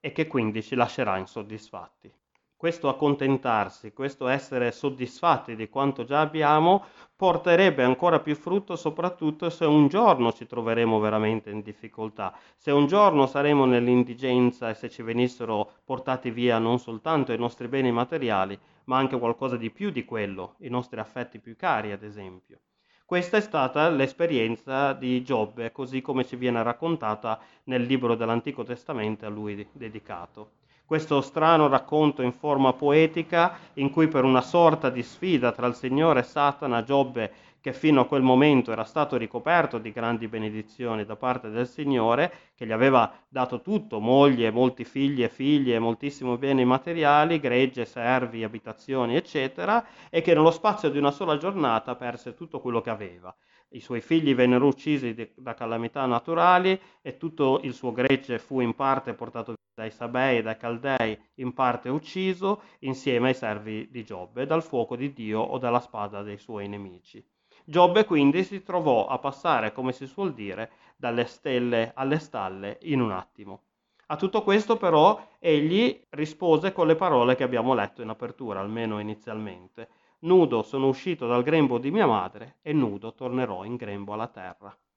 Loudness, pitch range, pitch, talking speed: -25 LUFS, 115-150 Hz, 125 Hz, 160 wpm